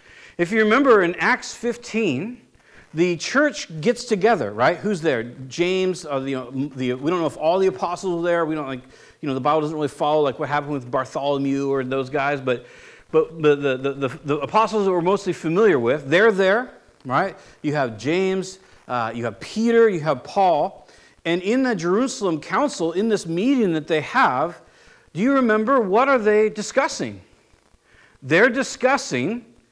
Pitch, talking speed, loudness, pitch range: 175 Hz, 185 wpm, -21 LUFS, 145-220 Hz